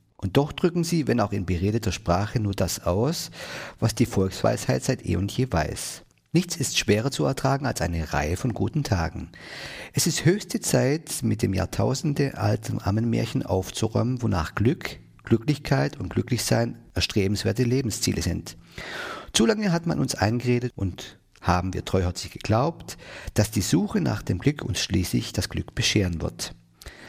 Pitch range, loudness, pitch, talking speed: 95-135 Hz, -25 LUFS, 110 Hz, 160 wpm